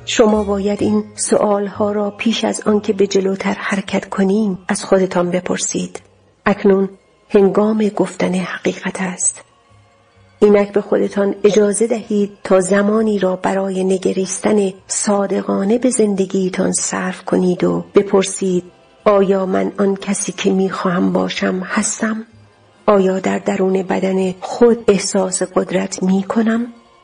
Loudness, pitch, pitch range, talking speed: -16 LUFS, 195 Hz, 185-210 Hz, 125 wpm